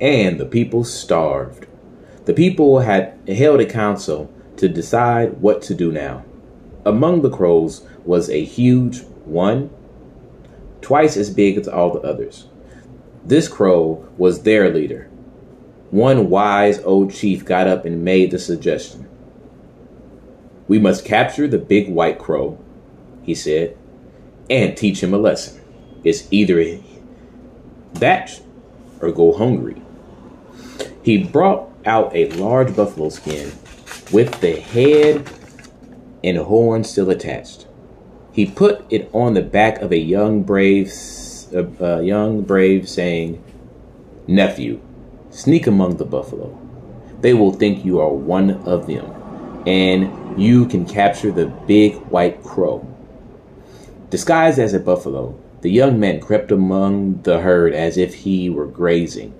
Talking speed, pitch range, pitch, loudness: 130 wpm, 85-110 Hz, 95 Hz, -16 LUFS